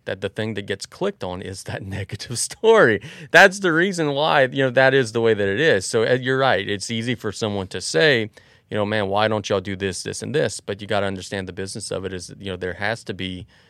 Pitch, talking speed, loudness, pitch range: 105 Hz, 265 wpm, -20 LUFS, 95-125 Hz